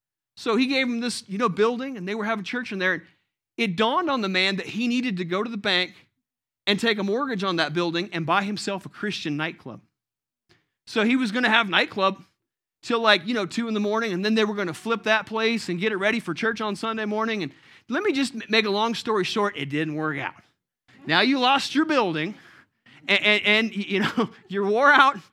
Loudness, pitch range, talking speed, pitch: -23 LUFS, 185-230 Hz, 235 wpm, 210 Hz